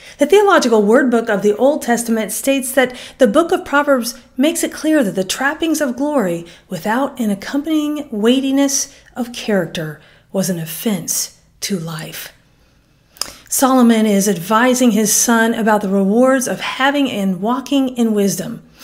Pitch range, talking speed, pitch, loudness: 205-275 Hz, 150 wpm, 240 Hz, -16 LUFS